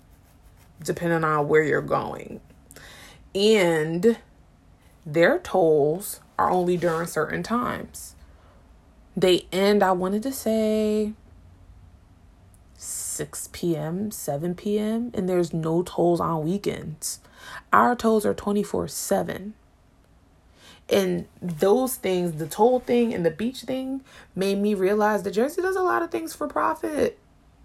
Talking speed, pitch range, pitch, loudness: 120 wpm, 140-215 Hz, 175 Hz, -24 LUFS